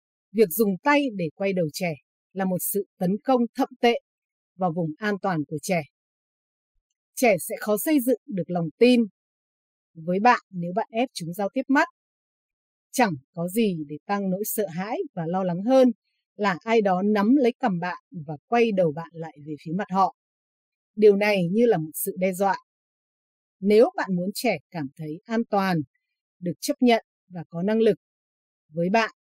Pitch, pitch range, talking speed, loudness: 195 Hz, 170-230 Hz, 185 wpm, -24 LUFS